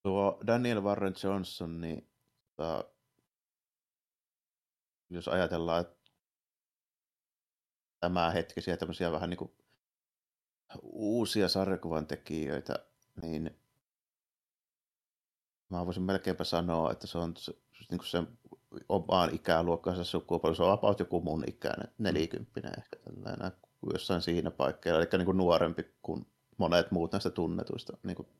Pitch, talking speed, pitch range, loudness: 85 Hz, 110 wpm, 85-95 Hz, -33 LUFS